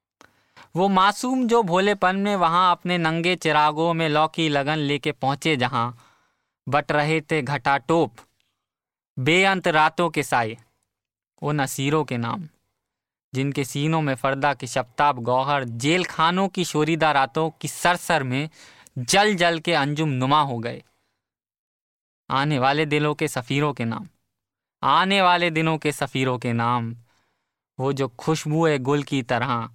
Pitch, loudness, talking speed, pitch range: 150 Hz, -22 LUFS, 145 wpm, 135-165 Hz